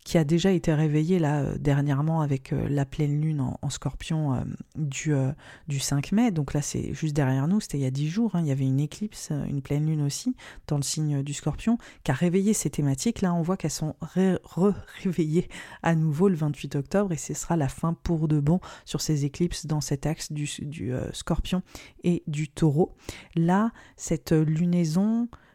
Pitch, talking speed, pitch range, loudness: 155 Hz, 215 wpm, 145-175 Hz, -27 LUFS